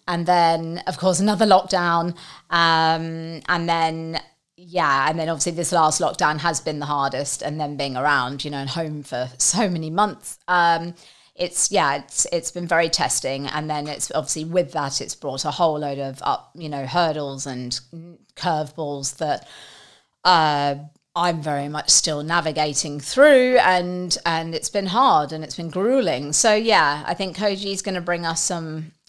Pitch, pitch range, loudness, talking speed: 165 Hz, 150-175 Hz, -21 LUFS, 175 wpm